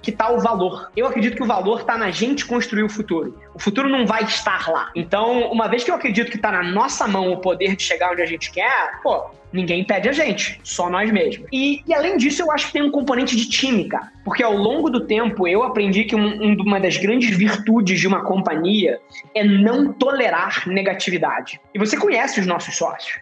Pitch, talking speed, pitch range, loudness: 220 Hz, 225 wpm, 190-250 Hz, -19 LUFS